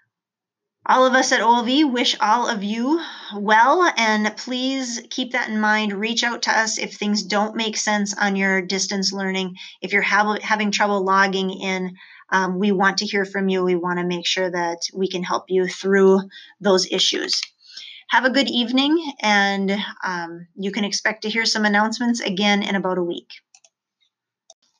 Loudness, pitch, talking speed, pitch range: -20 LUFS, 205 Hz, 175 wpm, 190-230 Hz